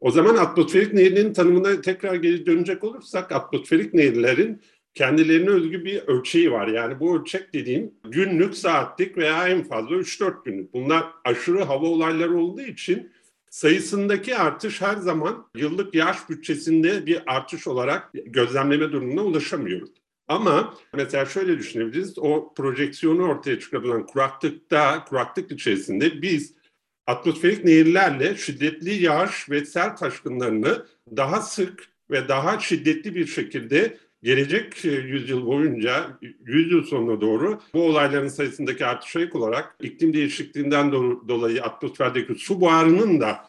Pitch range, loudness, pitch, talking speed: 150-205 Hz, -22 LUFS, 175 Hz, 125 wpm